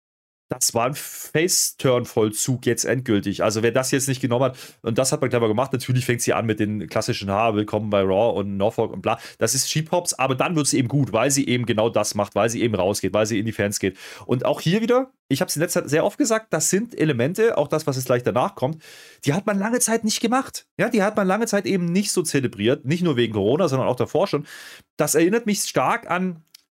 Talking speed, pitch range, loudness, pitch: 250 wpm, 115-175 Hz, -21 LUFS, 135 Hz